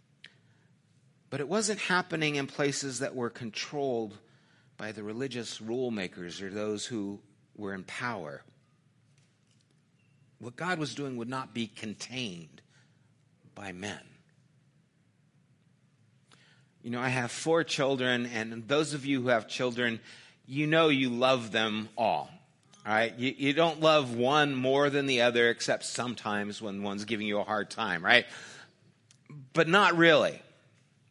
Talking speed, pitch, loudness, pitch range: 140 wpm, 130 Hz, -29 LUFS, 115-150 Hz